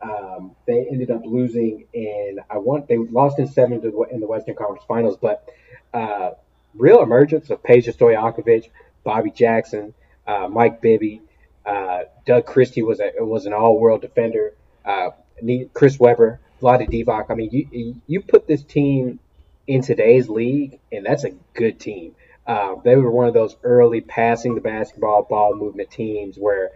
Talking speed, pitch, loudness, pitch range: 170 wpm, 120 Hz, -18 LUFS, 110-130 Hz